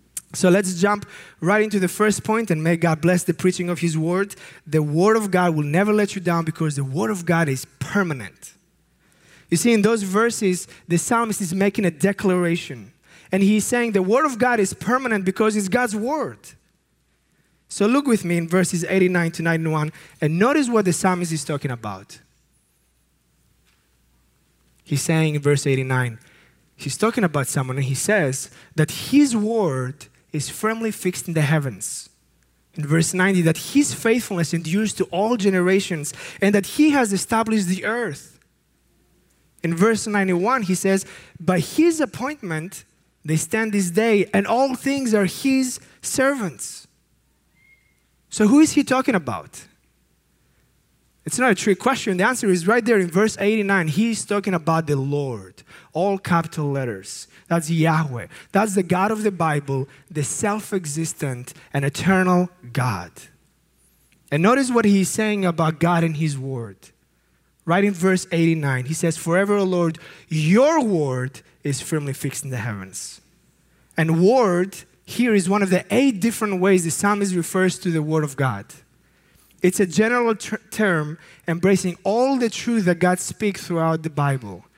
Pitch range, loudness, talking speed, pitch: 155-210 Hz, -21 LUFS, 165 wpm, 180 Hz